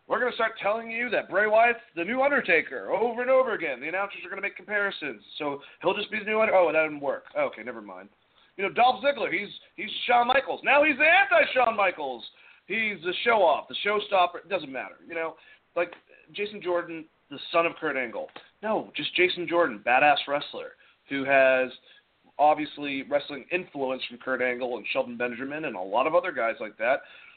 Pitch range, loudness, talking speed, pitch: 145-240 Hz, -26 LUFS, 200 wpm, 185 Hz